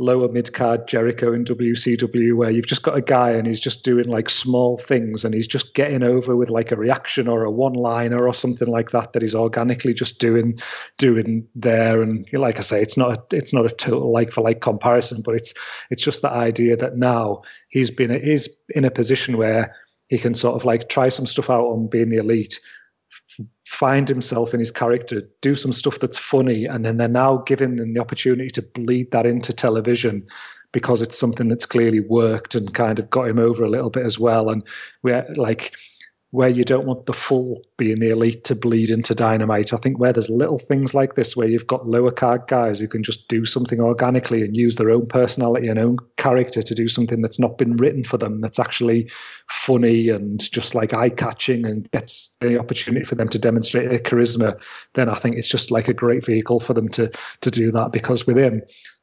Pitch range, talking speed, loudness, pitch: 115-125 Hz, 215 wpm, -19 LUFS, 120 Hz